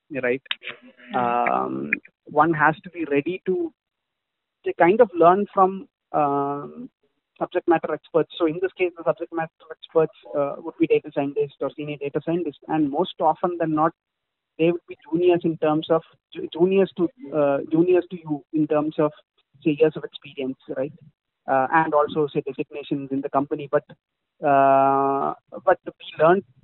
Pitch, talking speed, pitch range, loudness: 155 Hz, 165 wpm, 145-170 Hz, -23 LUFS